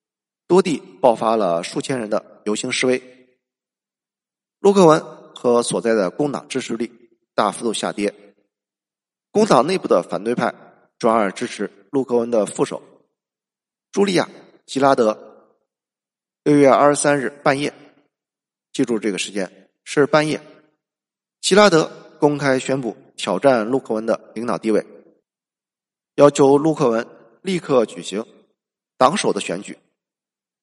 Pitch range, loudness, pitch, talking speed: 115-150 Hz, -19 LUFS, 135 Hz, 200 characters per minute